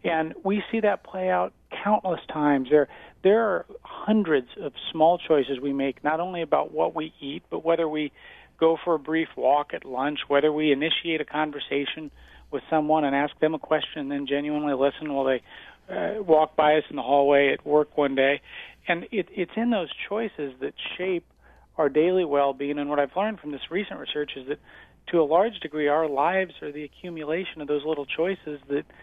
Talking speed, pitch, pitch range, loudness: 200 wpm, 155 Hz, 145-170 Hz, -25 LUFS